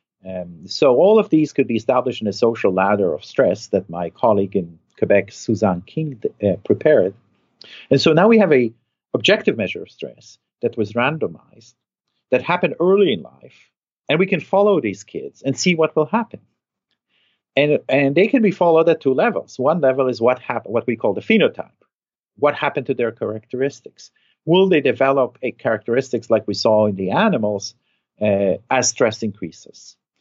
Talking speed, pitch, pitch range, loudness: 180 wpm, 135 Hz, 115-175 Hz, -18 LUFS